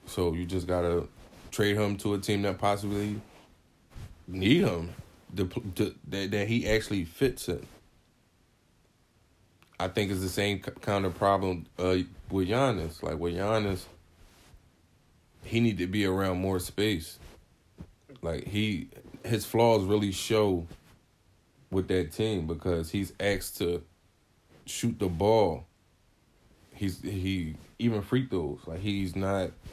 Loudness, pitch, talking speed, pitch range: -30 LUFS, 95 Hz, 135 wpm, 90-105 Hz